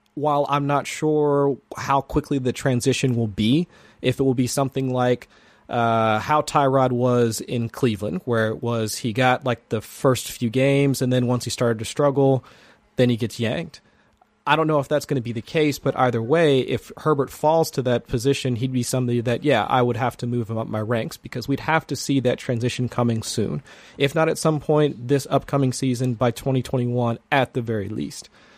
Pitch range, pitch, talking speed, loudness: 120-140 Hz, 130 Hz, 210 wpm, -22 LUFS